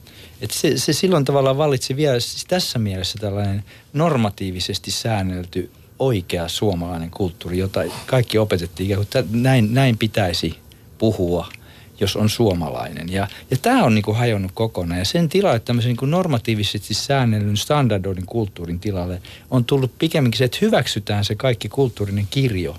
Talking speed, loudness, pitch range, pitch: 145 wpm, -20 LUFS, 95-130 Hz, 110 Hz